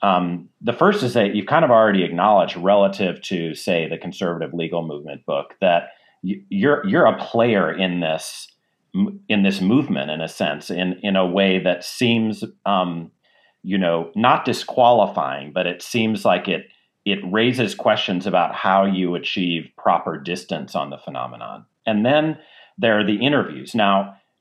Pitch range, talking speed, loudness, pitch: 90-110 Hz, 160 wpm, -20 LUFS, 95 Hz